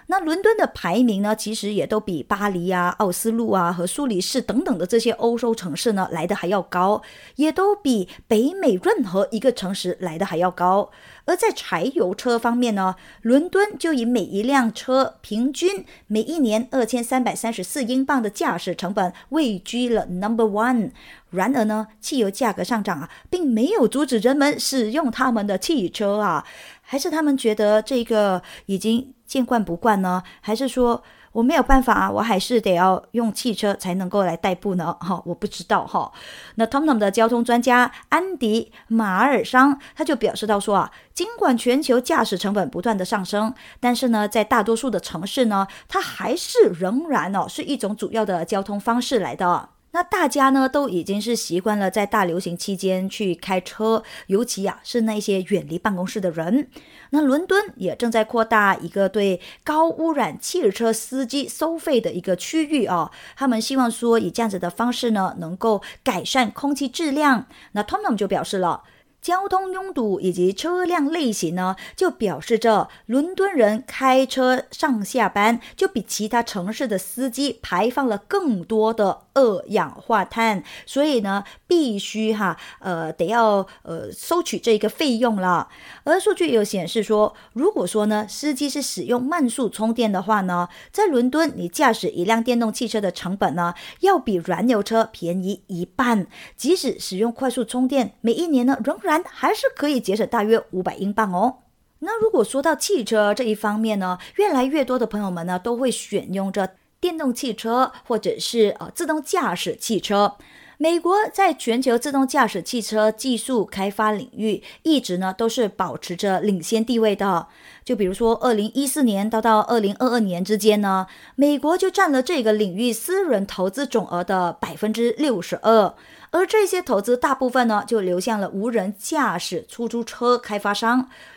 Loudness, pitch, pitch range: -21 LUFS, 230 Hz, 200-265 Hz